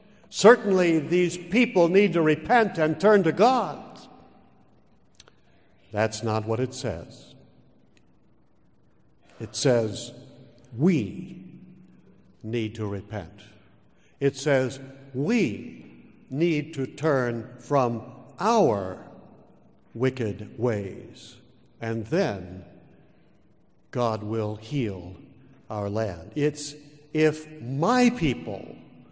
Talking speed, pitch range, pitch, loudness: 85 wpm, 110-160 Hz, 130 Hz, -25 LUFS